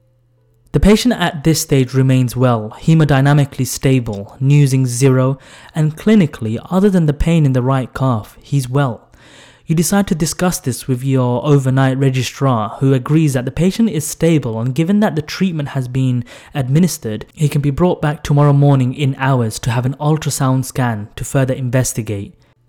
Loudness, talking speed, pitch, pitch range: -15 LUFS, 170 wpm, 135 Hz, 125-155 Hz